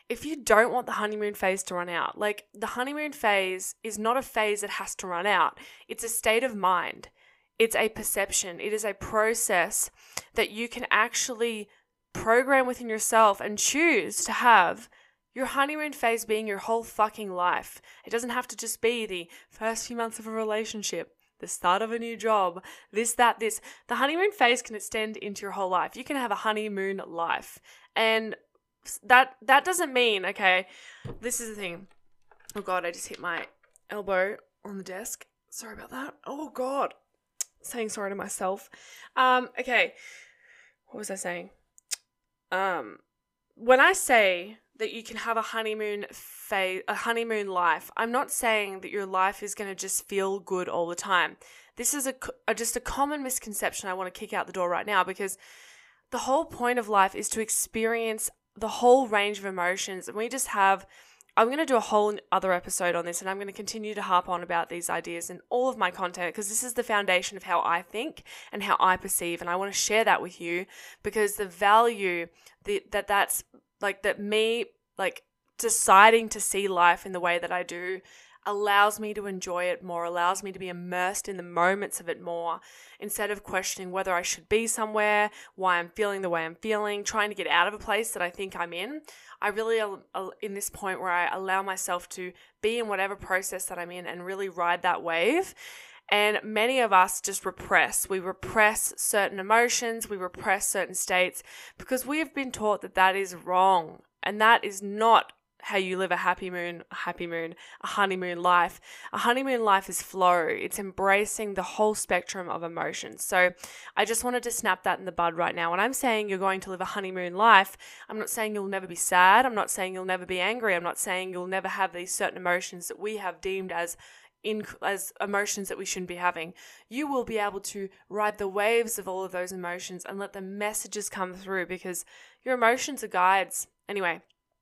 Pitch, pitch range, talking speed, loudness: 205 Hz, 185-225 Hz, 205 wpm, -27 LUFS